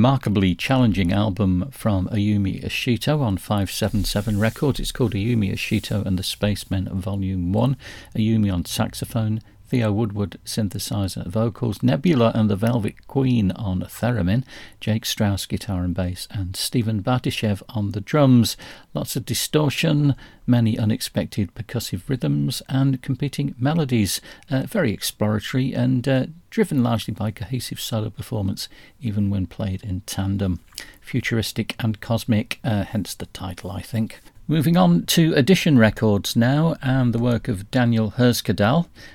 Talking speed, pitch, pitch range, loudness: 140 wpm, 110 Hz, 100-125 Hz, -22 LUFS